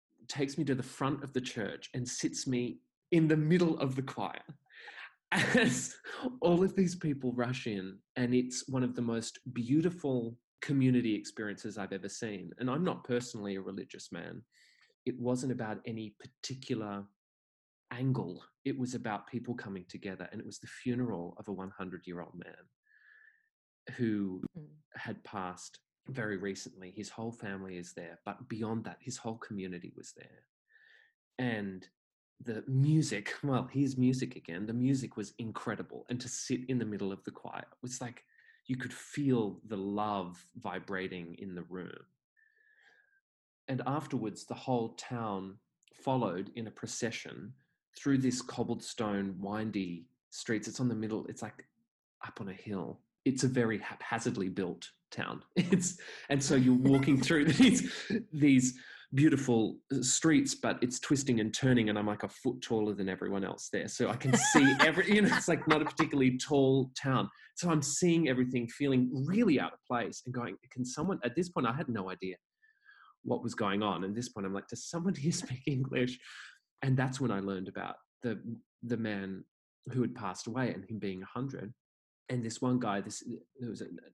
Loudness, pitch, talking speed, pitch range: -33 LUFS, 125 Hz, 175 wpm, 105-140 Hz